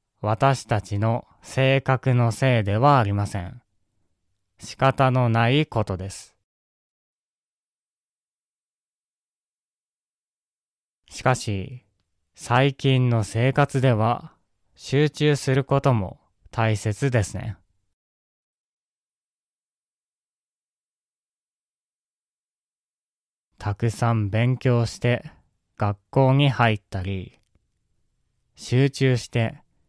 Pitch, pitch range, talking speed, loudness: 115 Hz, 100-130 Hz, 135 characters per minute, -22 LUFS